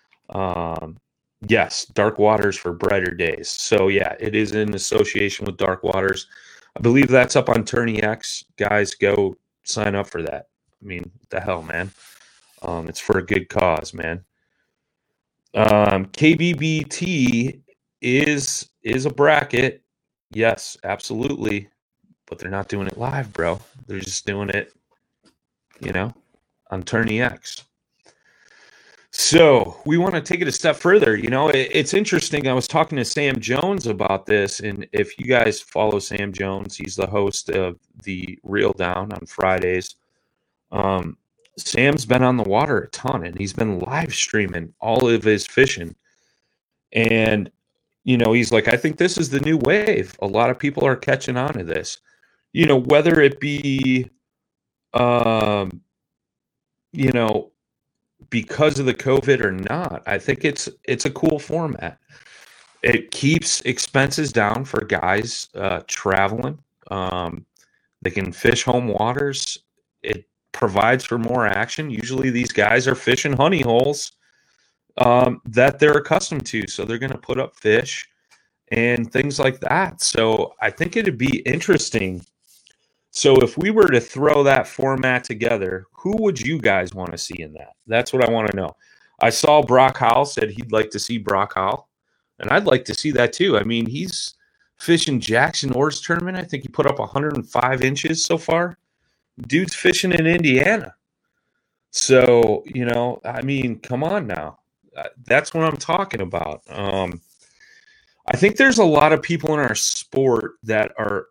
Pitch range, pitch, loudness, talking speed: 100-145 Hz, 120 Hz, -19 LUFS, 160 wpm